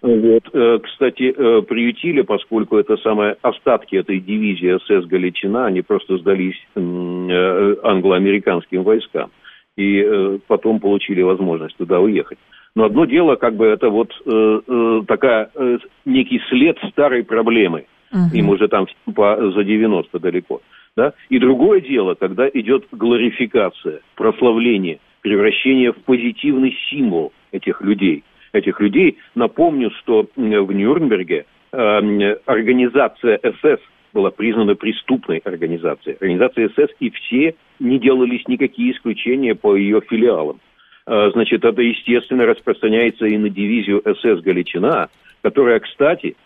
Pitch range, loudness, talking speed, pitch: 105-155 Hz, -16 LUFS, 115 wpm, 115 Hz